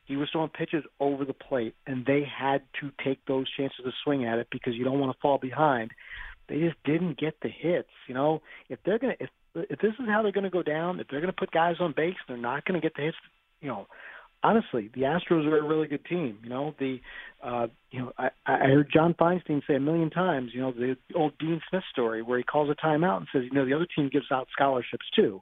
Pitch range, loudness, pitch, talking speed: 130-165 Hz, -28 LUFS, 145 Hz, 250 wpm